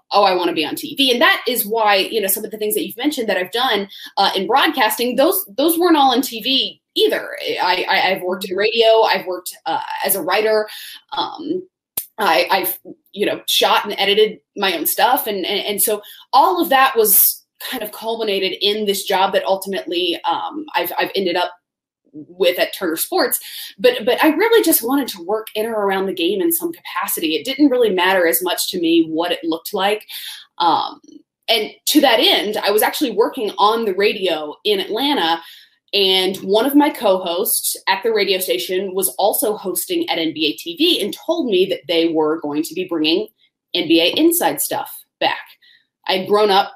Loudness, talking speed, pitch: -17 LUFS, 200 wpm, 220 Hz